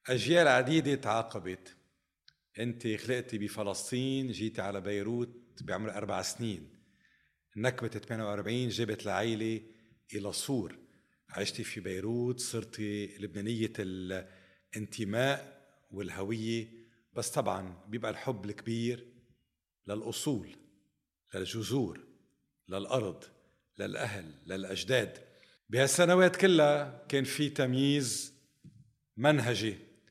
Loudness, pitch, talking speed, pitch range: -33 LUFS, 115 Hz, 80 wpm, 105-125 Hz